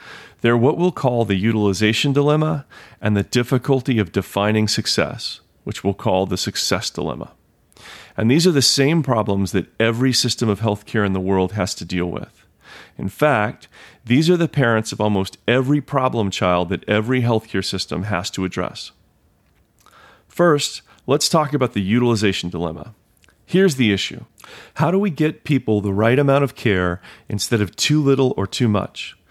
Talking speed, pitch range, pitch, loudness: 170 wpm, 100-135 Hz, 110 Hz, -19 LUFS